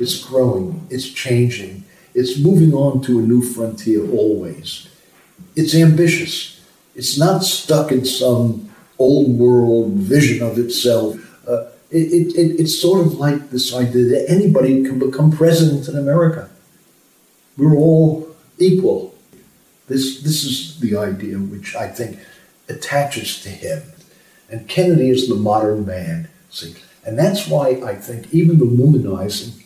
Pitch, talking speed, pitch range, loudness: 140 Hz, 140 wpm, 120-165 Hz, -16 LUFS